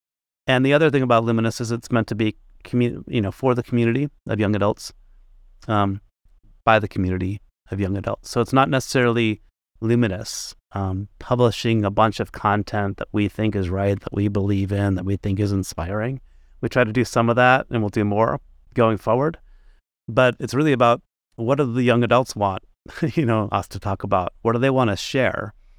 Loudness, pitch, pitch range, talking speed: -21 LUFS, 110 Hz, 100-120 Hz, 200 wpm